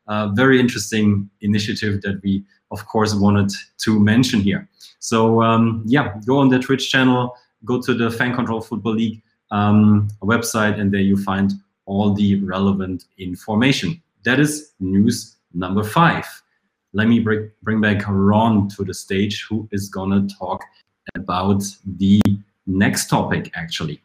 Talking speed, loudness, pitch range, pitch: 150 wpm, -19 LUFS, 100-115 Hz, 105 Hz